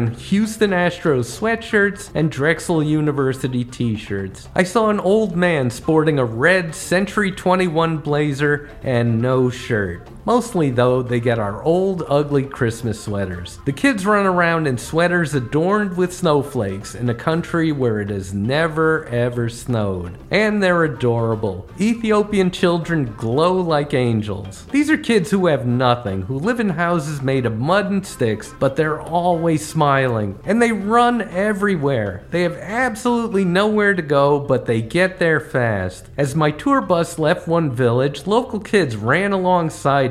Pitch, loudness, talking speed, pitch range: 155 Hz, -19 LUFS, 155 wpm, 125-185 Hz